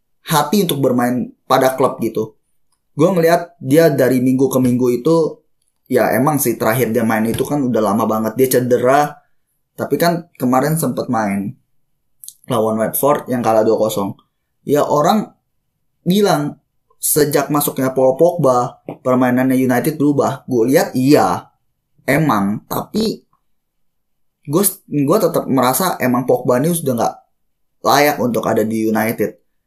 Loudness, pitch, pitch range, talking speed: -16 LUFS, 130 Hz, 115-150 Hz, 130 wpm